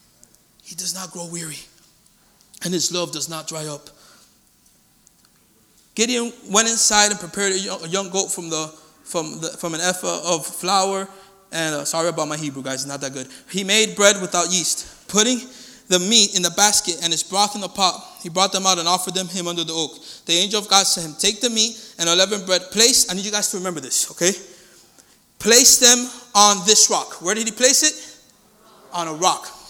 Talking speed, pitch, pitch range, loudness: 205 wpm, 185 Hz, 170-210 Hz, -18 LUFS